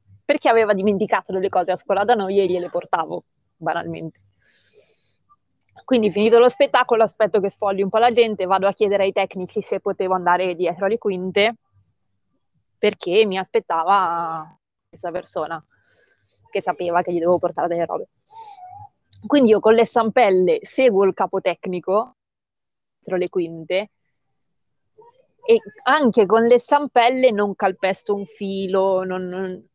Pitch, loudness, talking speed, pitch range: 195 Hz, -19 LUFS, 145 wpm, 180-230 Hz